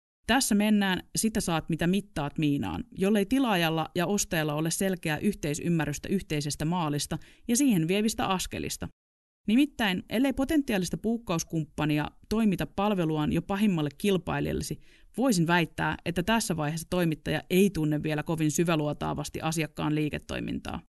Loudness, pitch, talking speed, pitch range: -28 LUFS, 175 Hz, 120 wpm, 155-205 Hz